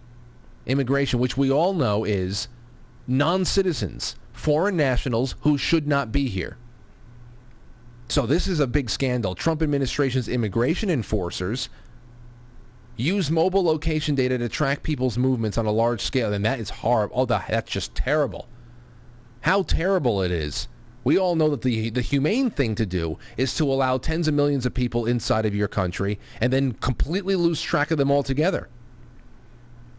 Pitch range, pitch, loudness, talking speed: 120-145 Hz, 125 Hz, -24 LUFS, 155 wpm